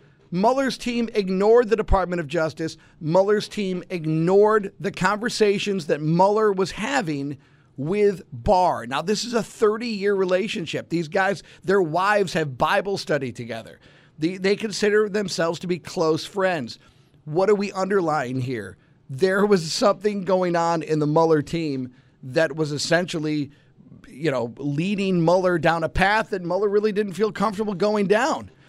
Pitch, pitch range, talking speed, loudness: 180 Hz, 155-205 Hz, 150 wpm, -22 LUFS